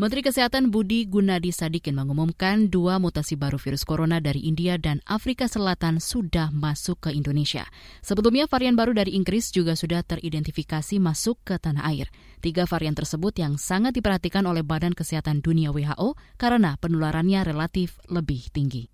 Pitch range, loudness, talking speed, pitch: 155-200 Hz, -24 LUFS, 150 wpm, 170 Hz